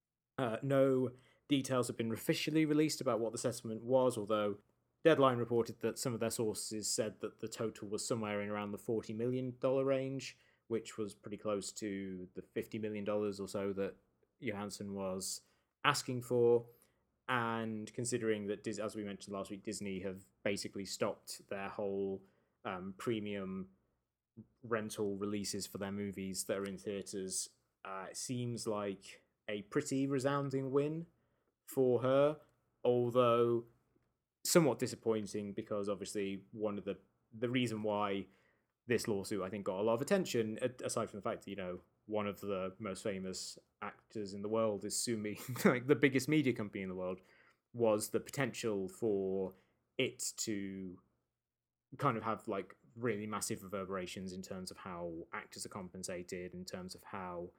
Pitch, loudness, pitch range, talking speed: 110 Hz, -38 LUFS, 100-125 Hz, 160 wpm